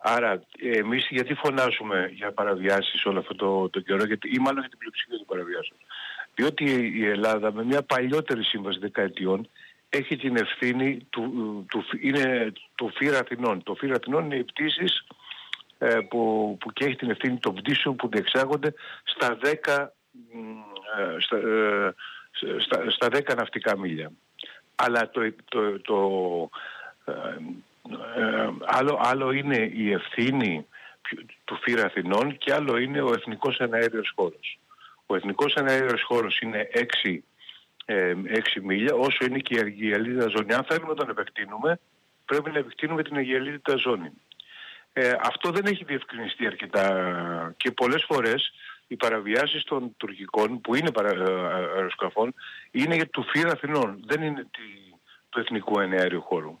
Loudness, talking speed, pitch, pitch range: -26 LUFS, 140 wpm, 125 Hz, 110-145 Hz